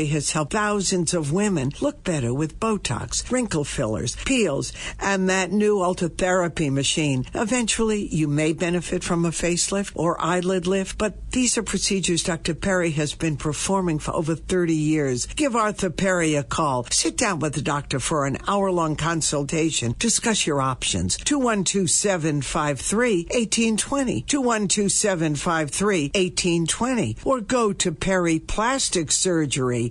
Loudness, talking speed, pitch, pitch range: -22 LUFS, 135 wpm, 175 Hz, 150-200 Hz